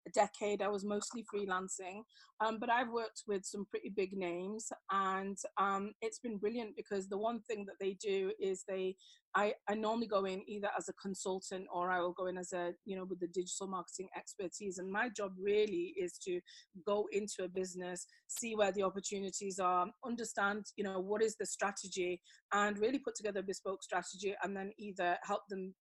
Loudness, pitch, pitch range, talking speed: -39 LUFS, 200 Hz, 190-215 Hz, 200 wpm